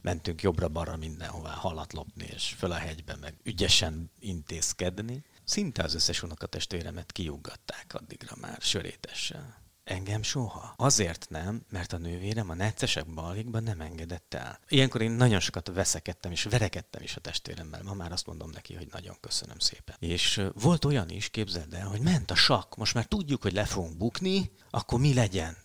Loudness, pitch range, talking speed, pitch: -30 LUFS, 85-115 Hz, 165 wpm, 95 Hz